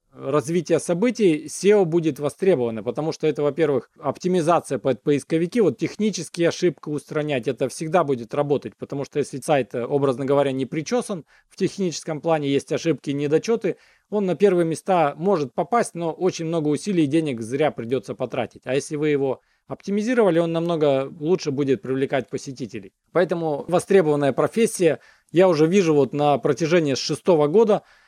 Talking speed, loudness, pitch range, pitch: 150 wpm, -22 LUFS, 140-175 Hz, 155 Hz